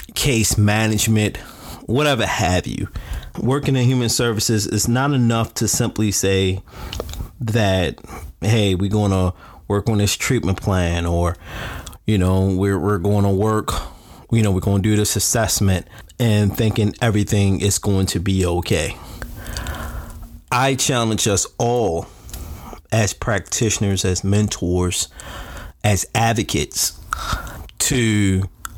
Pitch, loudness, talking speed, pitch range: 100 Hz, -19 LUFS, 125 wpm, 95-110 Hz